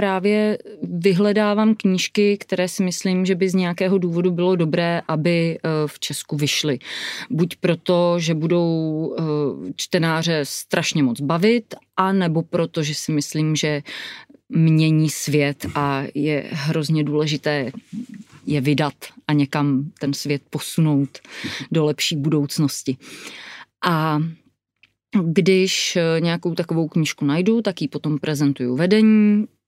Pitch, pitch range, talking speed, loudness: 160 Hz, 150-185 Hz, 120 wpm, -20 LUFS